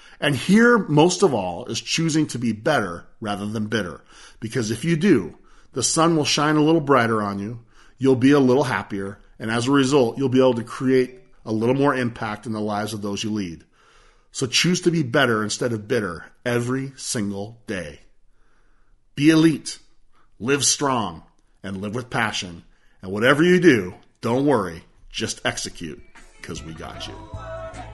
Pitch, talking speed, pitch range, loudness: 120 Hz, 175 wpm, 105-140 Hz, -21 LUFS